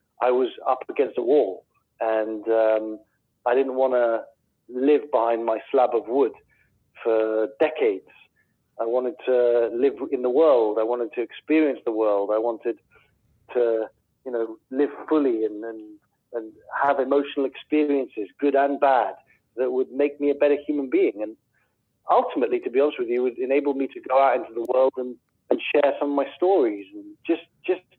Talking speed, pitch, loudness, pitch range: 180 wpm, 130 Hz, -23 LUFS, 115-145 Hz